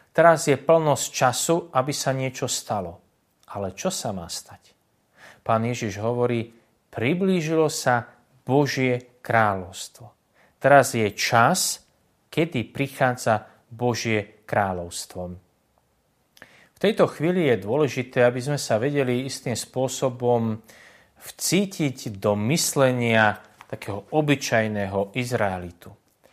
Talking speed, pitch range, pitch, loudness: 100 wpm, 110-140 Hz, 125 Hz, -23 LUFS